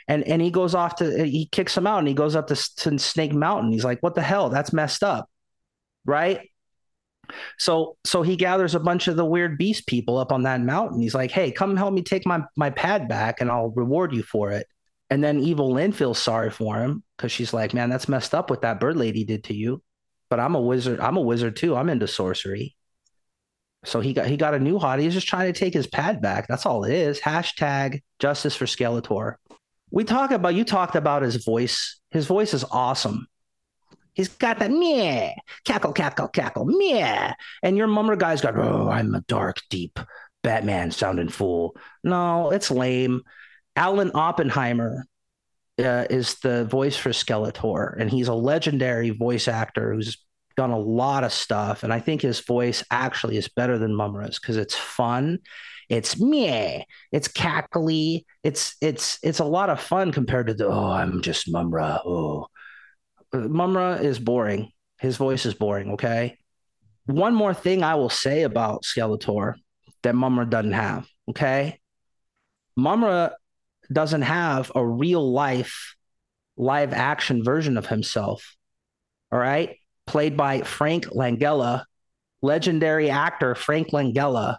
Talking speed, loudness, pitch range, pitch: 175 wpm, -23 LUFS, 120-165 Hz, 135 Hz